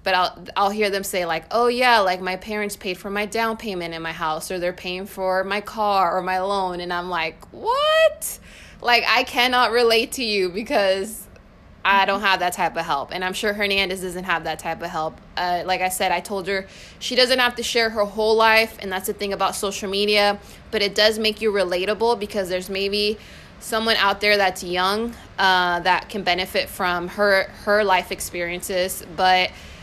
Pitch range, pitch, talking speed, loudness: 185-215 Hz, 195 Hz, 205 wpm, -21 LUFS